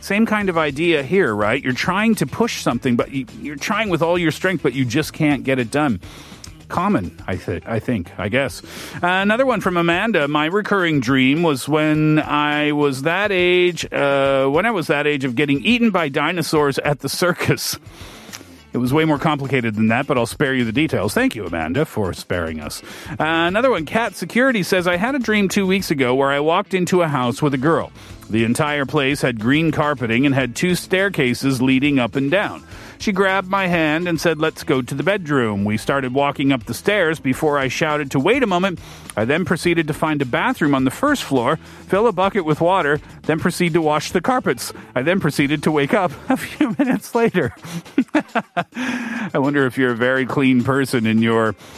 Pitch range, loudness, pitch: 135-180 Hz, -18 LUFS, 150 Hz